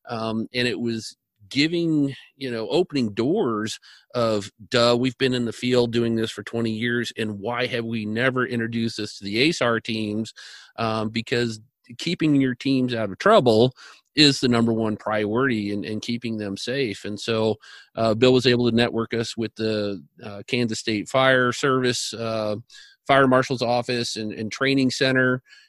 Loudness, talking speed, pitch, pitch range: -23 LUFS, 170 wpm, 115 Hz, 110-125 Hz